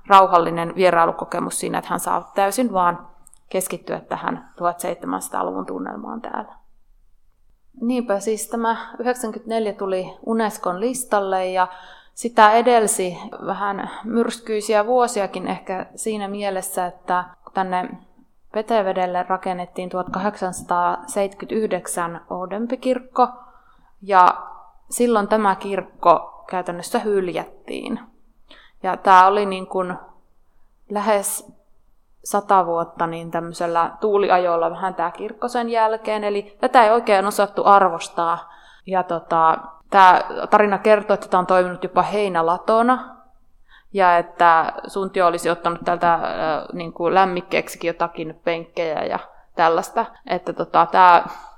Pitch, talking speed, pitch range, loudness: 195 Hz, 100 wpm, 180-220 Hz, -20 LUFS